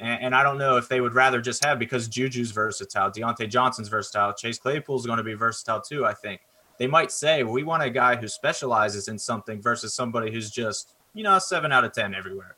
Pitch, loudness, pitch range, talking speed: 120 Hz, -24 LUFS, 110-130 Hz, 230 wpm